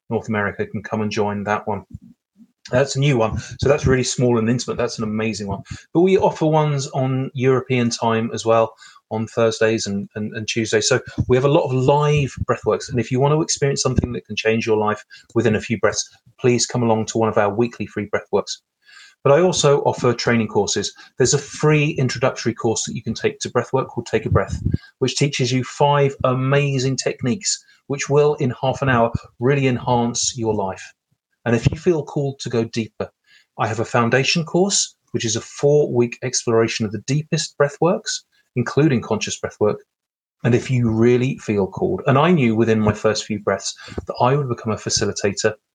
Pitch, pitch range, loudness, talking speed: 125 Hz, 110-140 Hz, -20 LUFS, 200 wpm